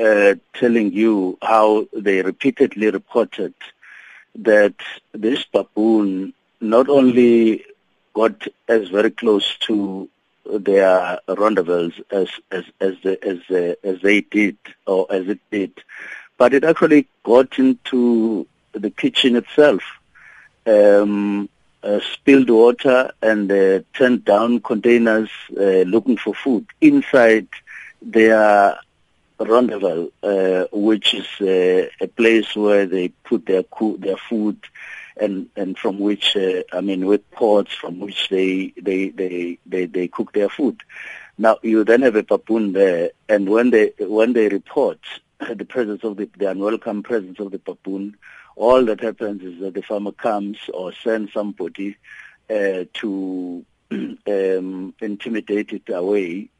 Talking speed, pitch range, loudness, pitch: 135 wpm, 95-115 Hz, -18 LUFS, 105 Hz